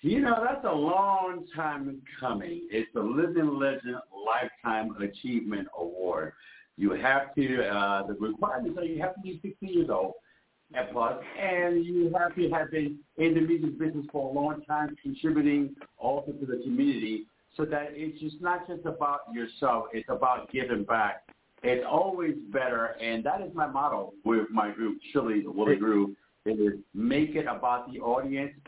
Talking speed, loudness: 175 wpm, -30 LUFS